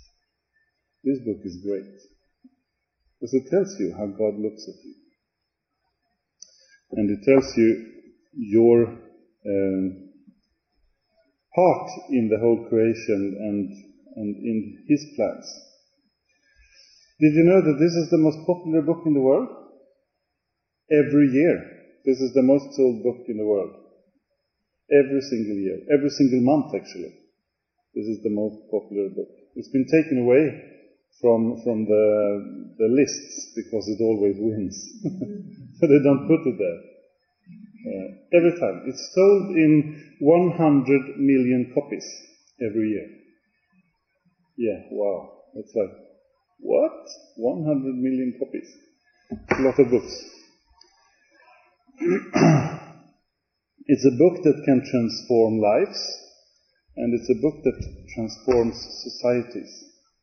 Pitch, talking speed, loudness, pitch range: 135 Hz, 120 wpm, -22 LUFS, 115-185 Hz